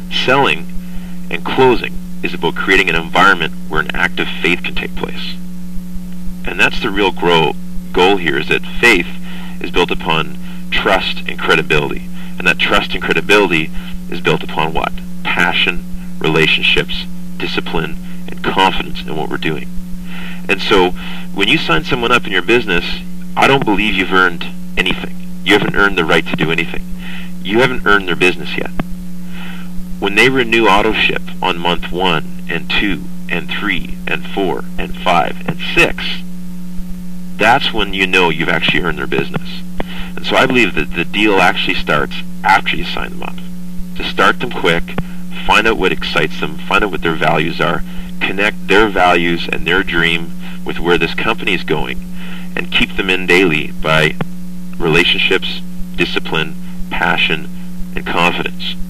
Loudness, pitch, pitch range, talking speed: -14 LUFS, 180 Hz, 175-180 Hz, 160 wpm